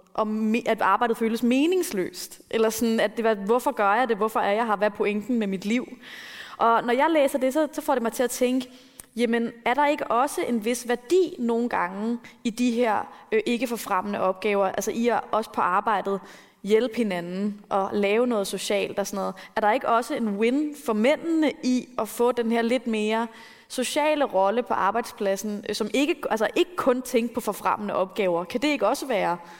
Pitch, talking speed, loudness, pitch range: 230 Hz, 205 wpm, -25 LUFS, 210-250 Hz